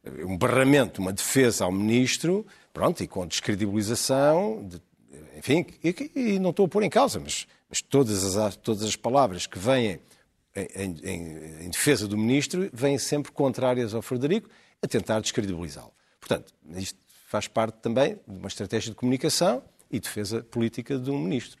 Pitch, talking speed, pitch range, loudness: 120 Hz, 165 wpm, 100-145 Hz, -26 LUFS